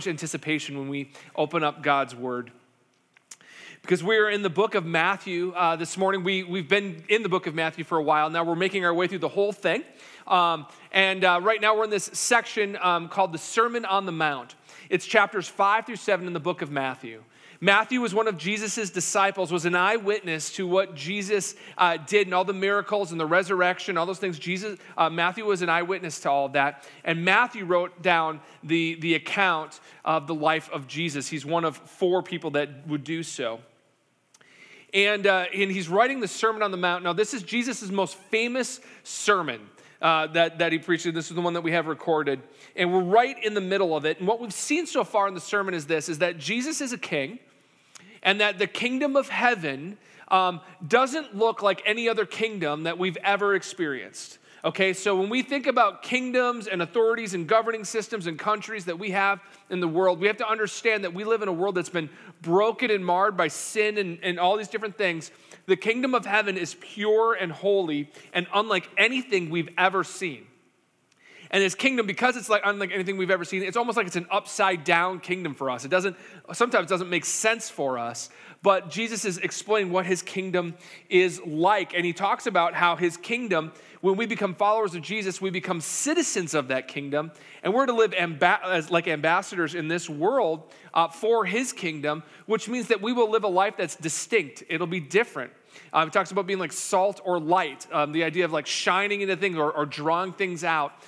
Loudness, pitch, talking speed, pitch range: -25 LUFS, 185 Hz, 210 wpm, 165-210 Hz